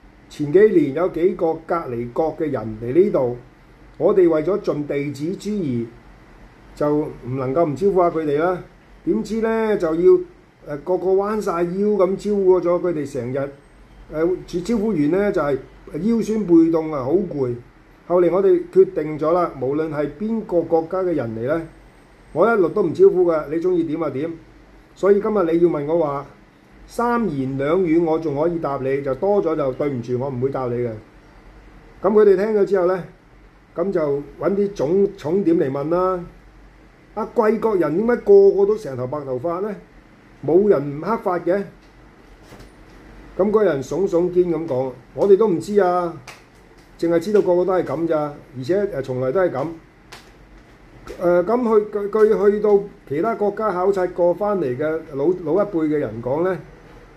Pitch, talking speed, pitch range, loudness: 175 Hz, 245 characters per minute, 150-200 Hz, -20 LUFS